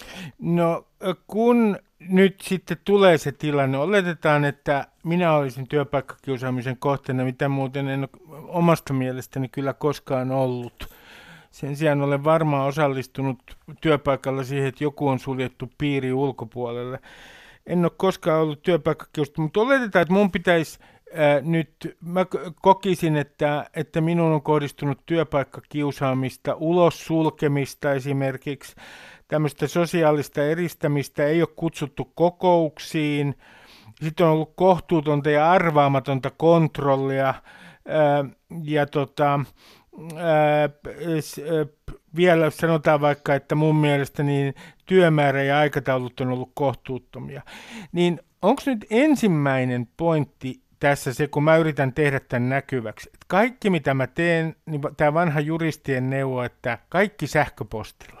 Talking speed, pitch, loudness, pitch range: 115 wpm, 150 Hz, -22 LUFS, 135-165 Hz